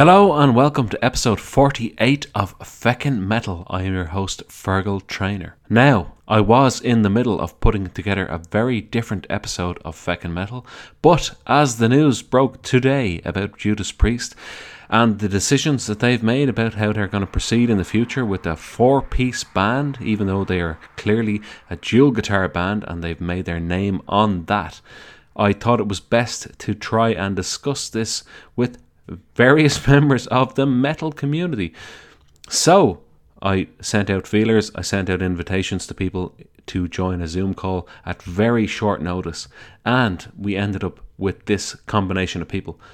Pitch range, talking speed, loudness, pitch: 95-120 Hz, 170 wpm, -19 LUFS, 105 Hz